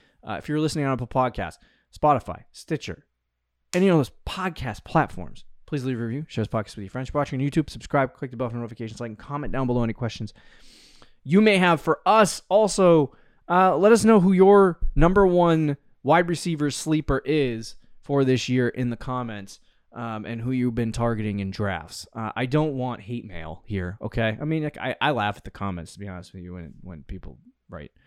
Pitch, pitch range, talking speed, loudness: 125 Hz, 110-150 Hz, 215 wpm, -23 LUFS